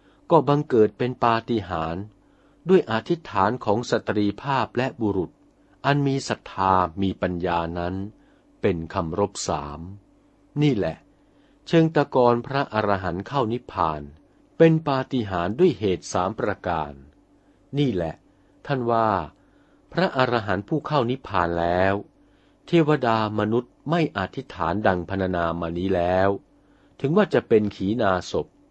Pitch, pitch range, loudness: 105 Hz, 90-135 Hz, -23 LUFS